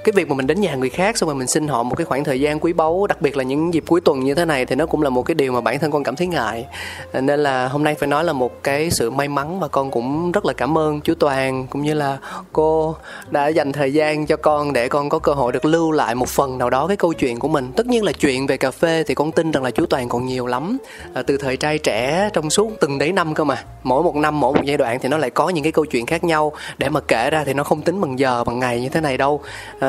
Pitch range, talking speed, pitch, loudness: 135-160 Hz, 305 wpm, 150 Hz, -19 LUFS